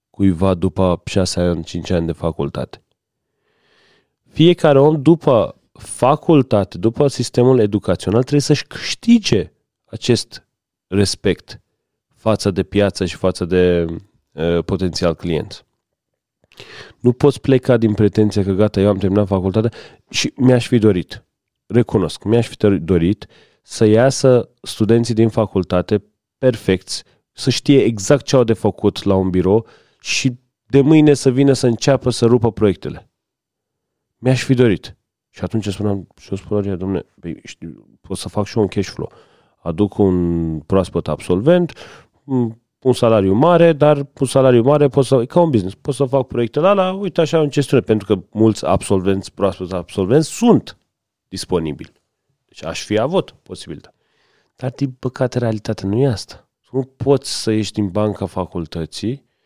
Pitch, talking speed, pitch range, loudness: 110 Hz, 145 wpm, 95-130 Hz, -16 LUFS